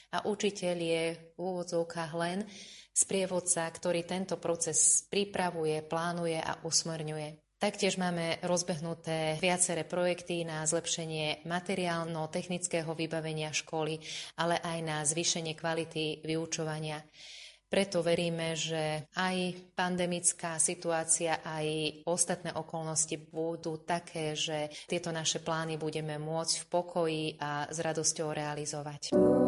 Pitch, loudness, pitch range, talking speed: 165 Hz, -32 LUFS, 155-175 Hz, 110 wpm